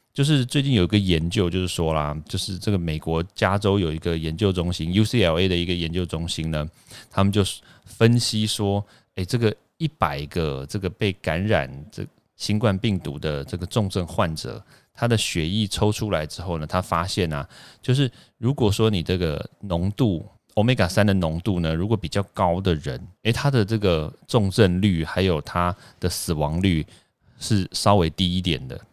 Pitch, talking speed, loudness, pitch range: 95 Hz, 270 characters per minute, -23 LUFS, 85-110 Hz